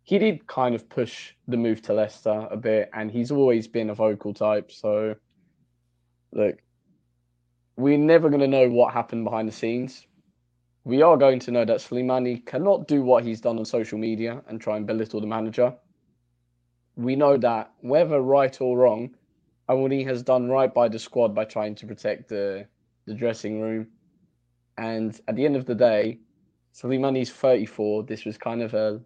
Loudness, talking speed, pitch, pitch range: -24 LUFS, 180 wpm, 115 Hz, 105-130 Hz